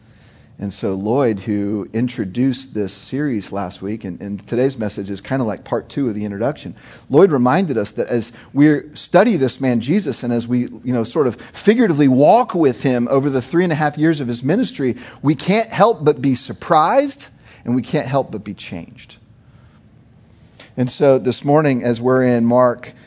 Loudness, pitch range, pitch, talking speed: -17 LUFS, 115-140 Hz, 125 Hz, 190 wpm